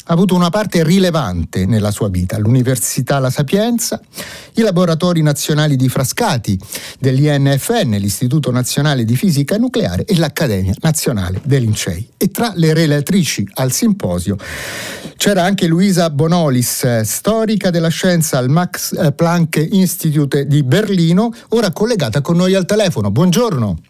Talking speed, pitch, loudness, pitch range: 135 wpm, 155 Hz, -14 LUFS, 125-185 Hz